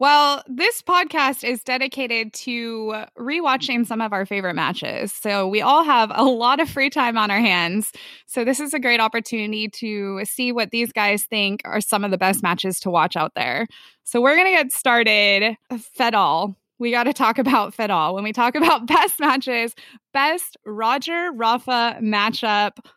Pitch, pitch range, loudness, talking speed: 235 Hz, 210-265 Hz, -19 LUFS, 185 wpm